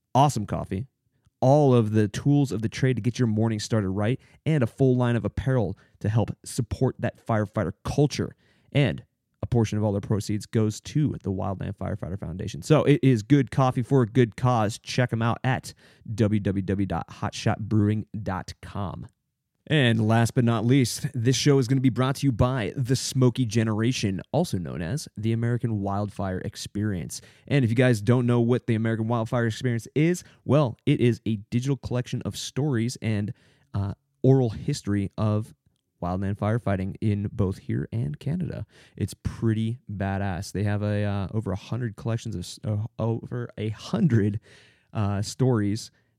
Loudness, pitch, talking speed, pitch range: -25 LUFS, 115 Hz, 170 wpm, 105-130 Hz